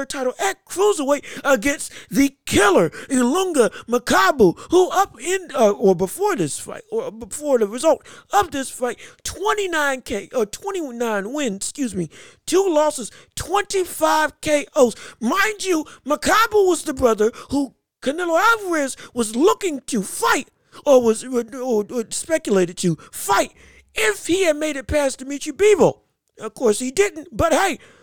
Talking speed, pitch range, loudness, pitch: 145 wpm, 245-370 Hz, -20 LUFS, 290 Hz